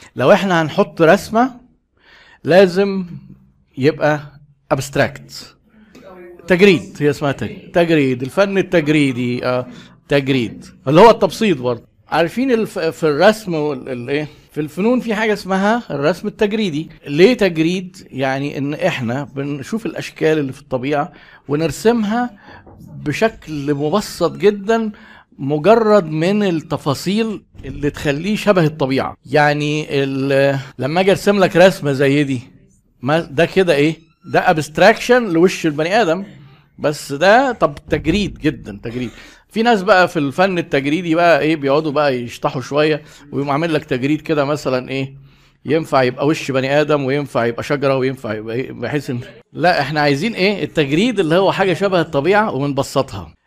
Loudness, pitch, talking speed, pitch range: -16 LUFS, 155 Hz, 130 wpm, 140-190 Hz